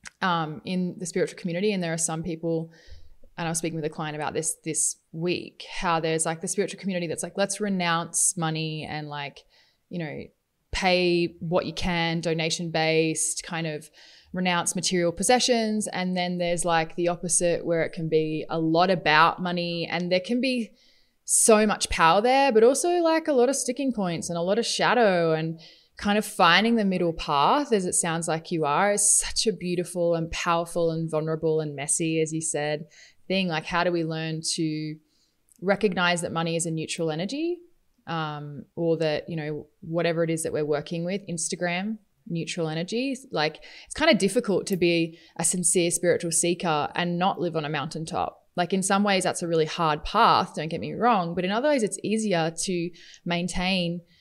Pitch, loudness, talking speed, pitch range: 170 Hz, -25 LUFS, 195 wpm, 160-190 Hz